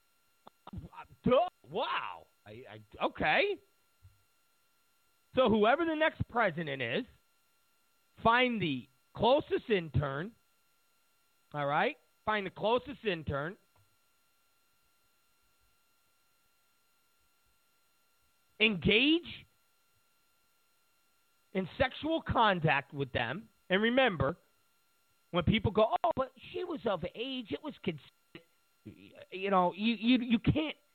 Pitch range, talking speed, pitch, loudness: 170-270 Hz, 95 wpm, 220 Hz, -31 LUFS